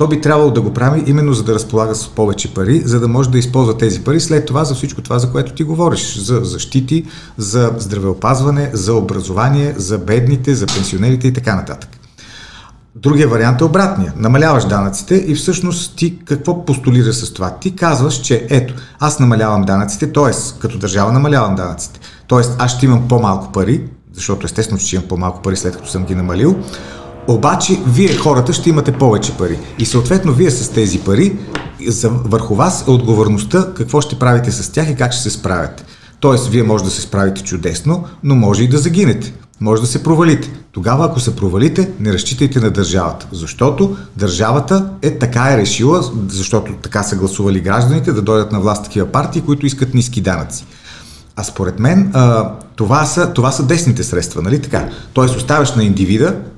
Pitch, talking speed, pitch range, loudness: 120 Hz, 180 wpm, 105-145 Hz, -14 LUFS